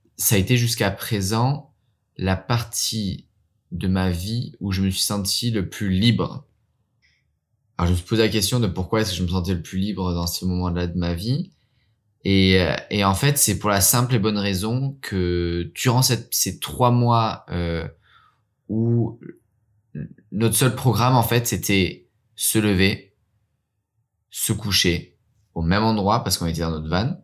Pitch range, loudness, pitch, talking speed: 95-115 Hz, -21 LUFS, 105 Hz, 175 wpm